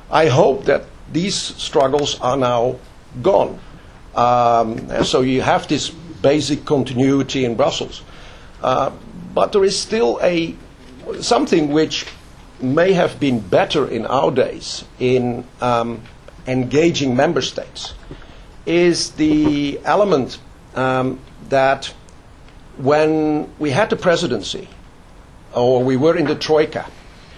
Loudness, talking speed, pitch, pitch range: -17 LUFS, 120 wpm, 140 Hz, 125-155 Hz